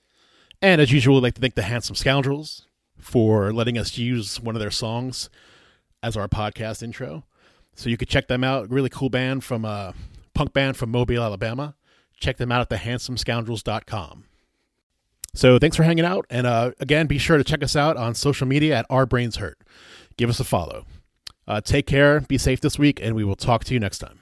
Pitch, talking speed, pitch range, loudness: 120 Hz, 210 wpm, 110-135 Hz, -22 LUFS